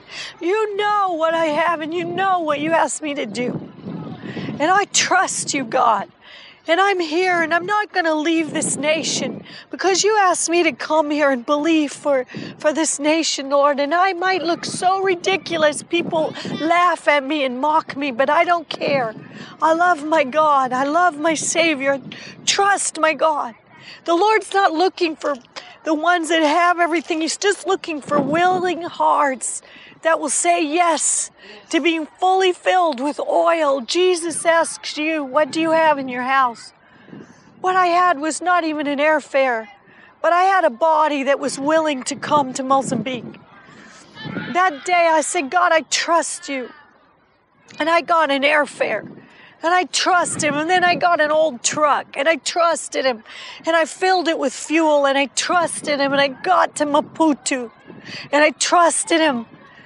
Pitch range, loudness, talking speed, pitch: 290-345 Hz, -18 LUFS, 175 wpm, 315 Hz